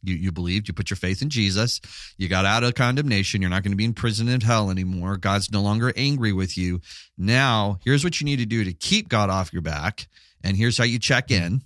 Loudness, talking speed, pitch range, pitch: -22 LUFS, 250 wpm, 95-120 Hz, 105 Hz